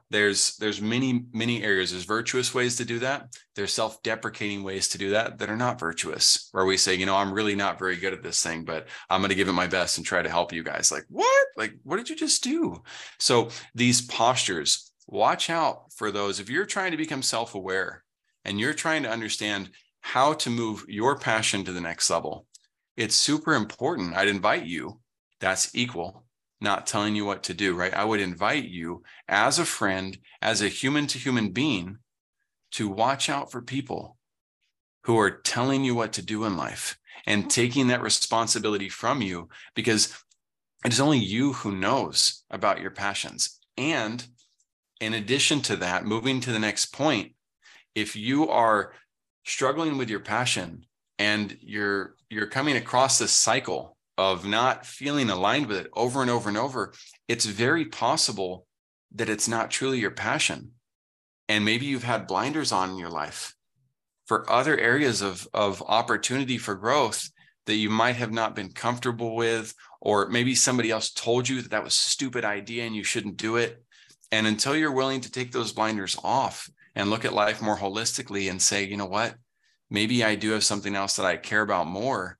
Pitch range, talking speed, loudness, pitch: 100-125 Hz, 185 wpm, -25 LUFS, 110 Hz